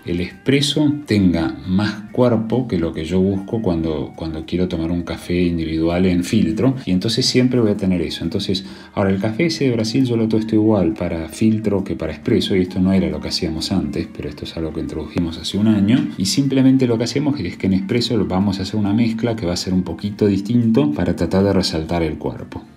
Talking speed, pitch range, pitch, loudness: 225 wpm, 85-115 Hz, 95 Hz, -19 LUFS